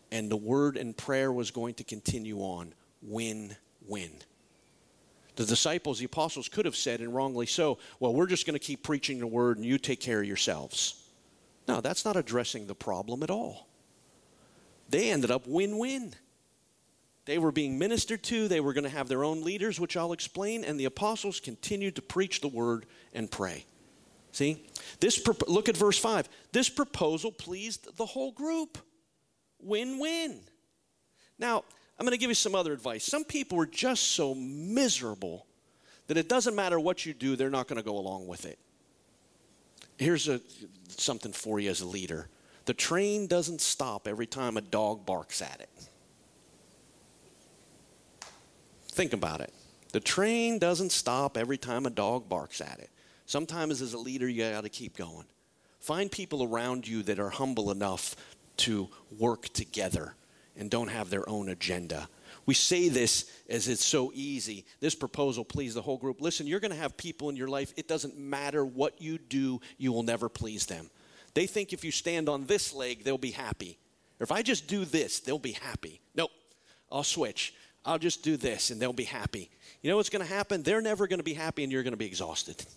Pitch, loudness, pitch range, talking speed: 135 Hz, -31 LUFS, 115-175 Hz, 185 wpm